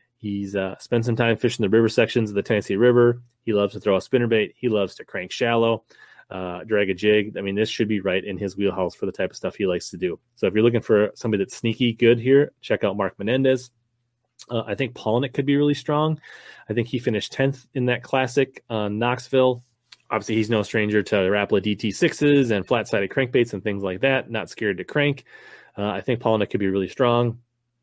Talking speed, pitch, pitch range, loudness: 230 wpm, 115 Hz, 105-125 Hz, -22 LUFS